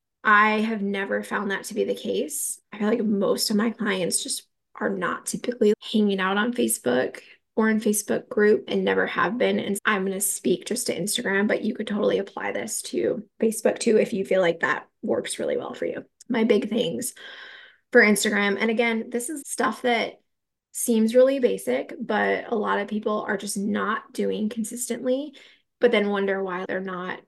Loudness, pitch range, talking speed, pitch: -24 LUFS, 200-235 Hz, 195 wpm, 215 Hz